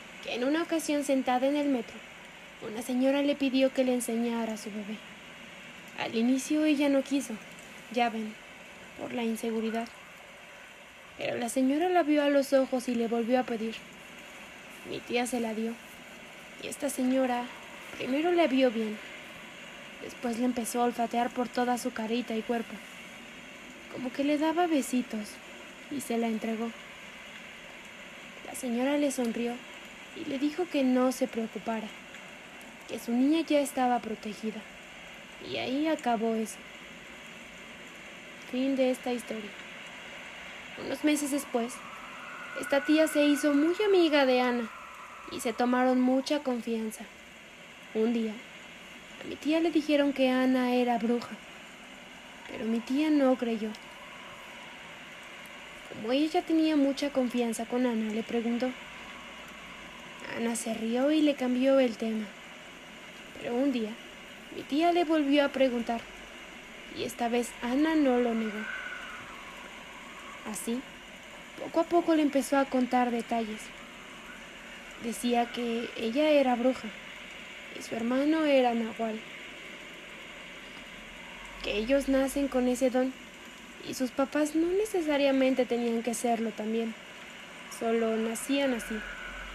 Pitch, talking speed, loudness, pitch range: 250 Hz, 135 wpm, -29 LUFS, 230-280 Hz